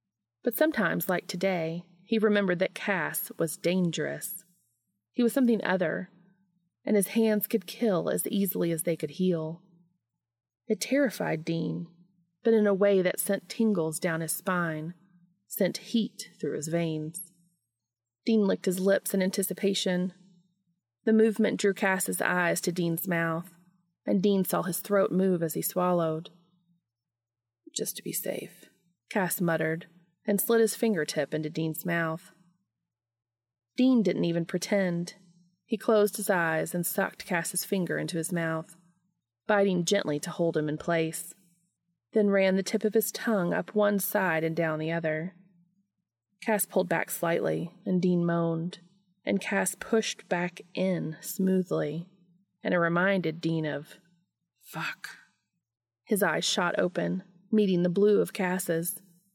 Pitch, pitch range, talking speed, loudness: 180 Hz, 165-195 Hz, 145 wpm, -28 LUFS